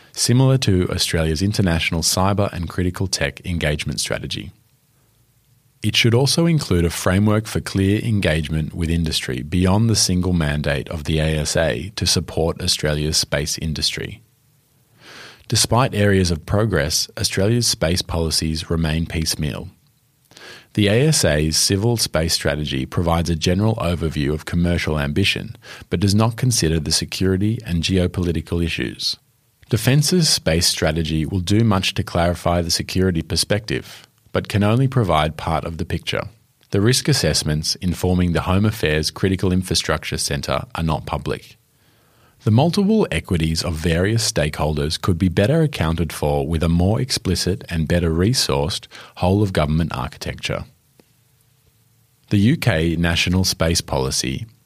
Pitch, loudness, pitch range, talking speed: 90 Hz, -19 LUFS, 80-110 Hz, 135 wpm